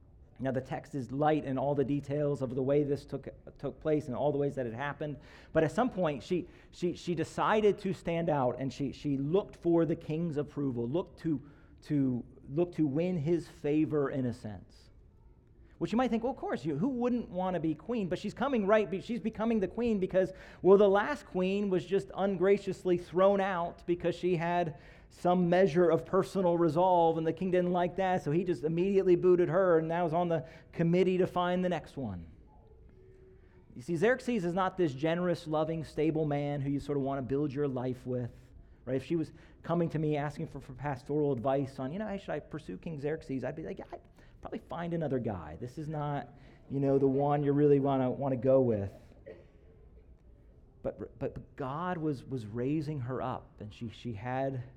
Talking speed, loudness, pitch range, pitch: 210 wpm, -32 LUFS, 135-180 Hz, 155 Hz